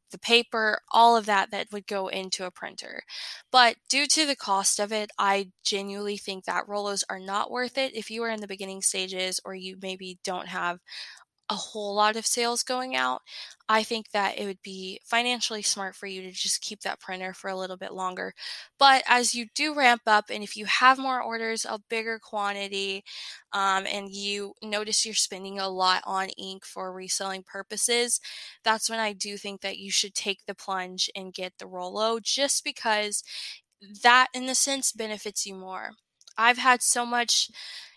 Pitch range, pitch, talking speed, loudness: 195-230 Hz, 205 Hz, 195 wpm, -26 LUFS